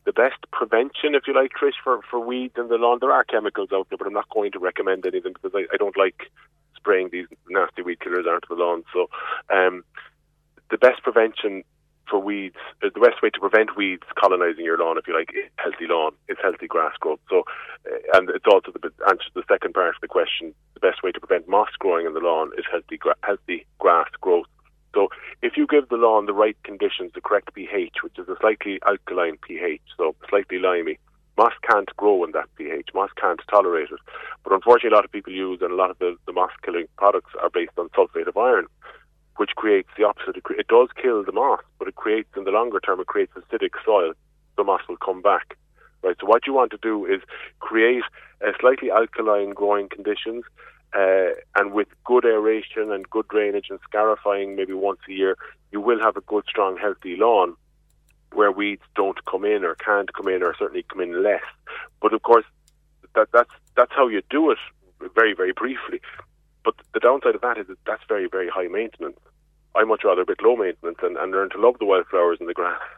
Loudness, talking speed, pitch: -22 LUFS, 215 wpm, 395 Hz